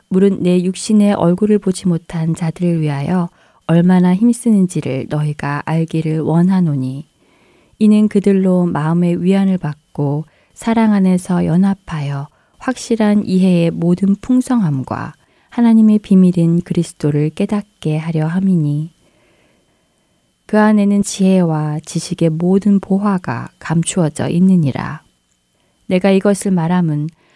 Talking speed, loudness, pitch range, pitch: 270 characters per minute, -15 LUFS, 160-200 Hz, 180 Hz